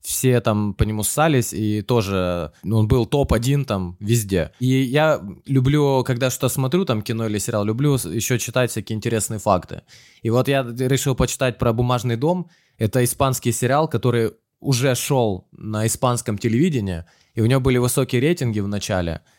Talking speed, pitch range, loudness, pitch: 165 wpm, 110-130 Hz, -20 LUFS, 120 Hz